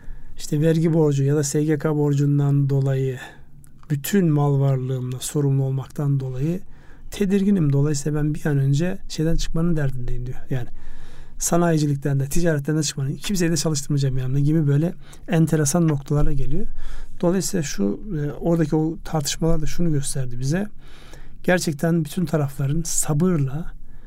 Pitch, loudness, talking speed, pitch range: 150 Hz, -22 LUFS, 130 wpm, 140-165 Hz